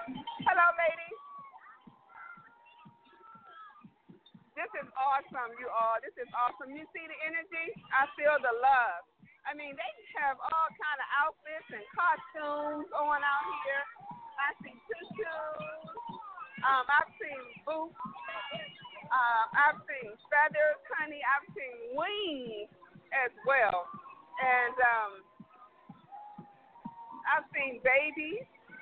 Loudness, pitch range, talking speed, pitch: -31 LUFS, 260-370 Hz, 110 wpm, 300 Hz